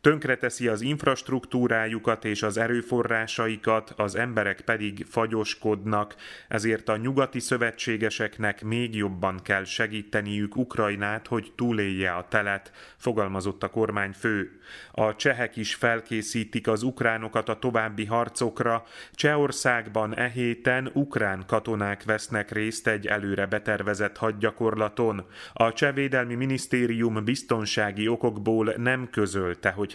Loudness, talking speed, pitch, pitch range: -27 LUFS, 110 wpm, 110 Hz, 105-120 Hz